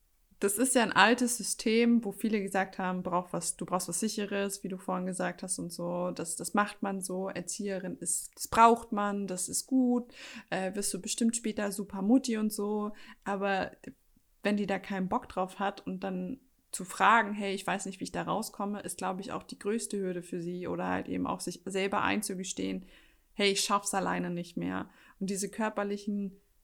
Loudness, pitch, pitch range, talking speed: -31 LUFS, 200 Hz, 185-215 Hz, 200 wpm